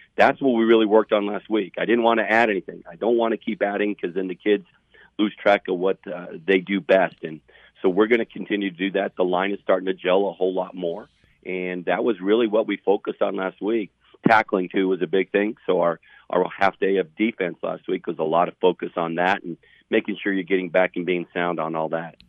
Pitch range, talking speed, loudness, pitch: 90-105 Hz, 255 wpm, -22 LUFS, 95 Hz